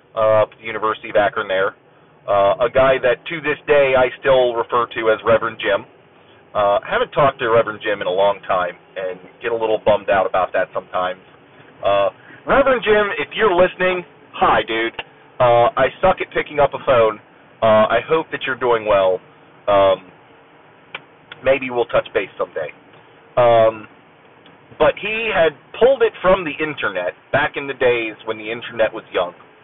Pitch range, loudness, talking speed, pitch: 110-150 Hz, -18 LUFS, 175 wpm, 120 Hz